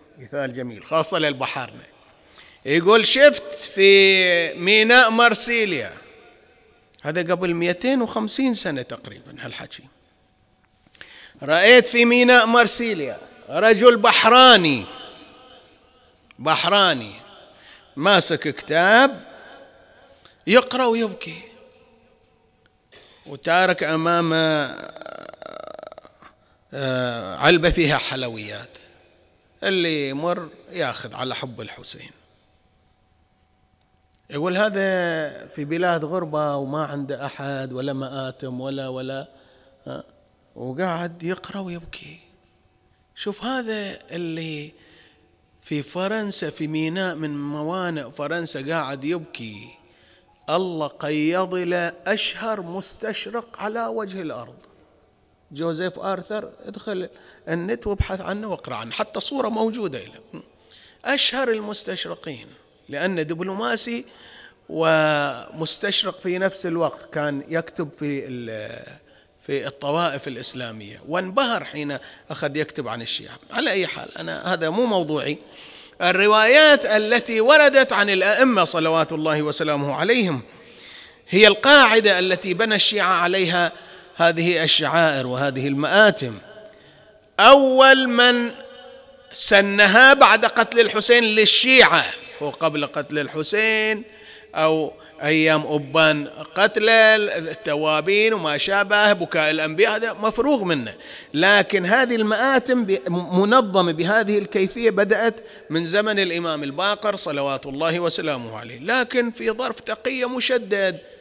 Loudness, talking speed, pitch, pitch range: -18 LUFS, 95 wpm, 175 Hz, 150-220 Hz